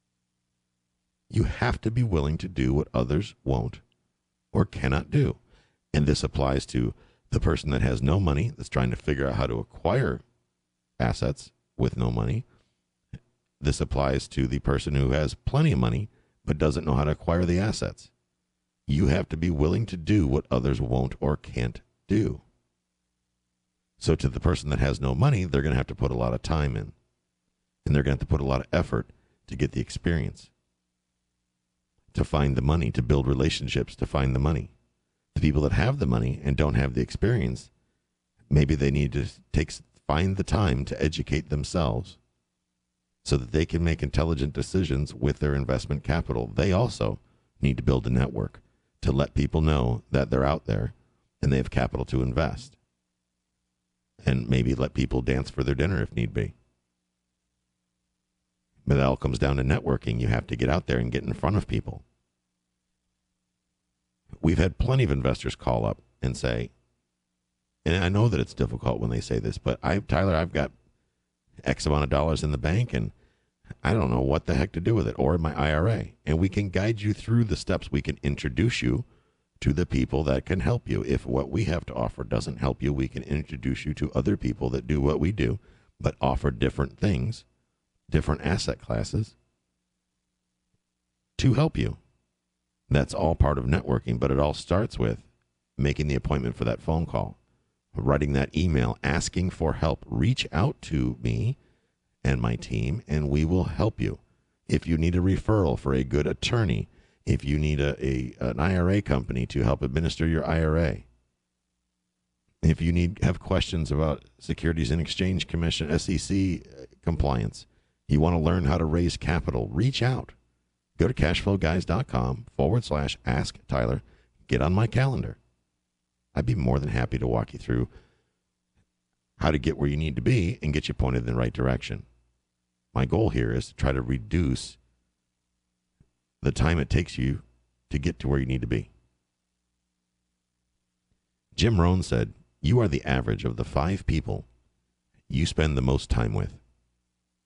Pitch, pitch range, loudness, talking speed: 65 Hz, 60-75 Hz, -27 LUFS, 180 wpm